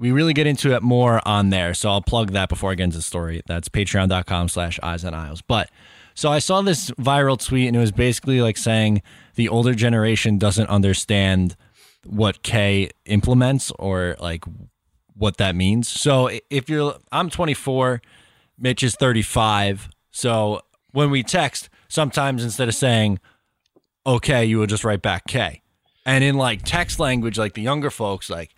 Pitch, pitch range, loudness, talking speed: 110 Hz, 100-130 Hz, -20 LUFS, 175 wpm